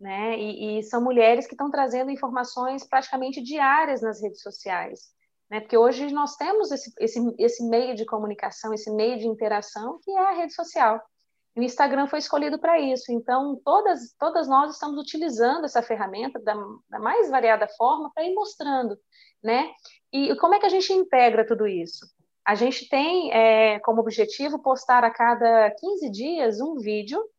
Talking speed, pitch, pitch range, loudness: 175 wpm, 250 Hz, 225-290 Hz, -23 LUFS